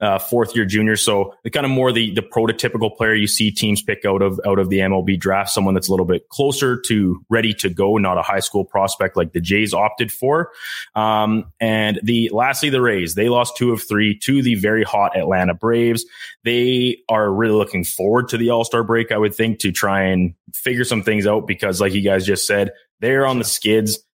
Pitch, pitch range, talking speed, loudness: 110 Hz, 100-115 Hz, 225 wpm, -18 LUFS